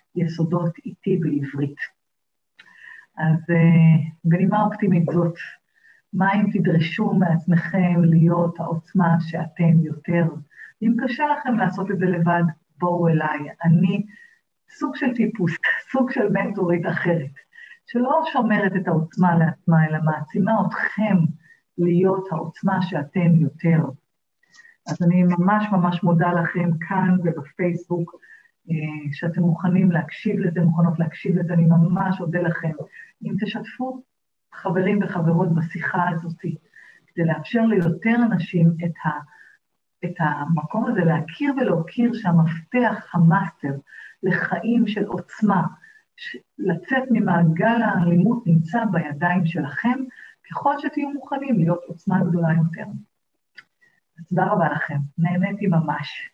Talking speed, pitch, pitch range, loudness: 110 wpm, 175 Hz, 165-210 Hz, -21 LUFS